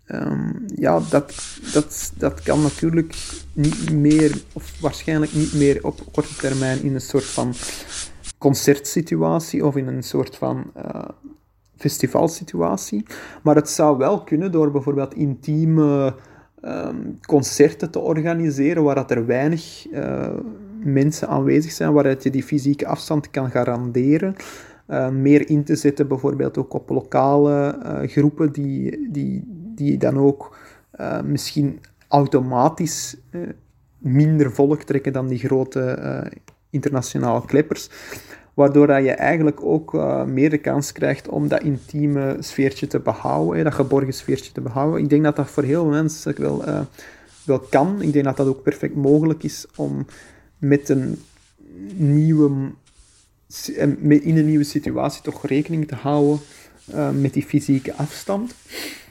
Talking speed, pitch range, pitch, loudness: 145 wpm, 135-150 Hz, 145 Hz, -20 LUFS